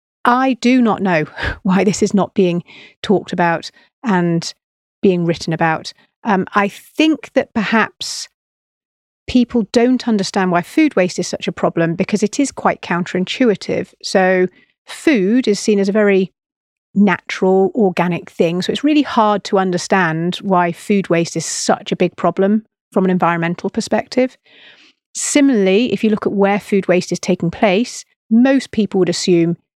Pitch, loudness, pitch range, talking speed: 195 Hz, -16 LUFS, 175-220 Hz, 155 wpm